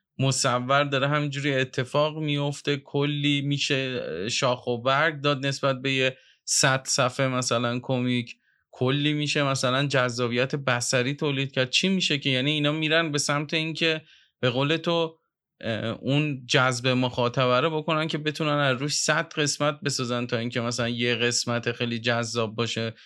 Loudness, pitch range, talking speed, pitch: -25 LUFS, 125-150 Hz, 150 wpm, 135 Hz